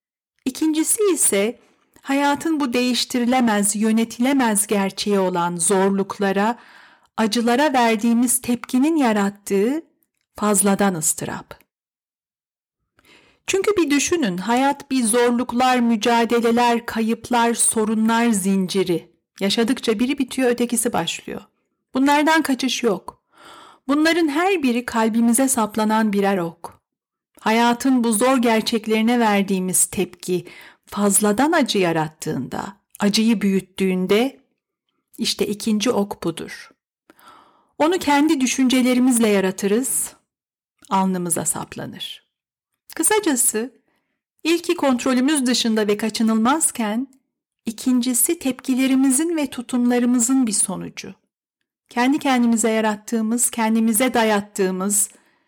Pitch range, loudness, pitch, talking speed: 210-265 Hz, -19 LUFS, 235 Hz, 85 wpm